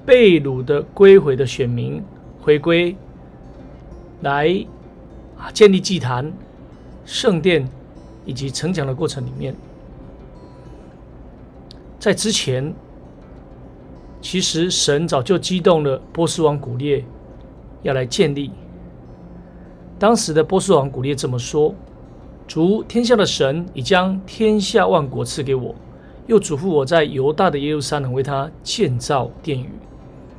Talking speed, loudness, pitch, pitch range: 180 characters per minute, -18 LUFS, 145 Hz, 130-180 Hz